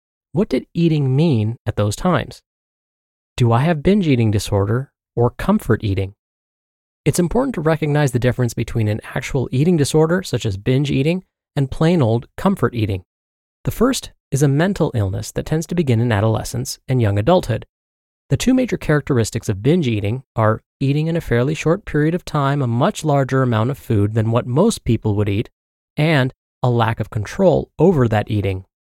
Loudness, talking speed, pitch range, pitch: -18 LUFS, 180 wpm, 110-155 Hz, 125 Hz